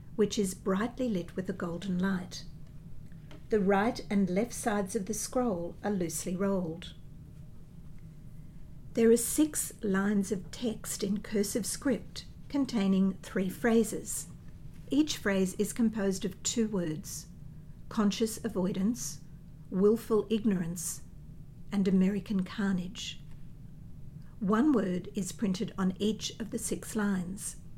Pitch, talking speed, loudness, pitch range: 195 Hz, 120 wpm, -31 LUFS, 165-215 Hz